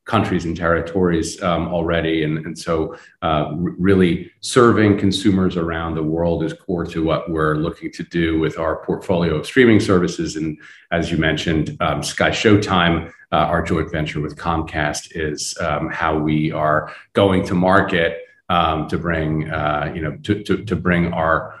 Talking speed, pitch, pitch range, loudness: 170 wpm, 85 Hz, 80-95 Hz, -19 LUFS